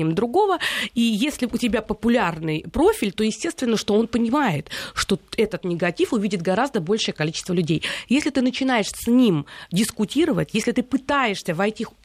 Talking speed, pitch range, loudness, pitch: 150 wpm, 190-250 Hz, -22 LUFS, 220 Hz